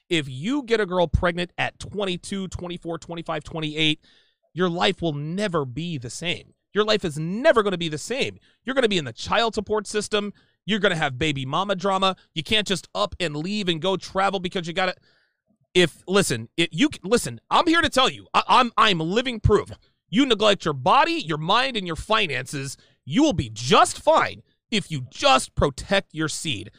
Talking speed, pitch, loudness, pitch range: 200 wpm, 185 Hz, -23 LUFS, 160-215 Hz